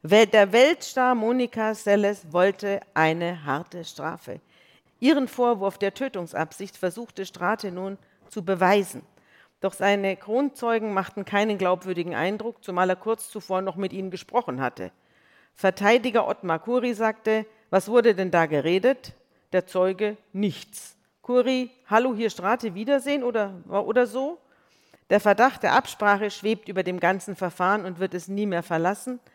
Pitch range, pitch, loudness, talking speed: 185-230 Hz, 205 Hz, -24 LUFS, 140 wpm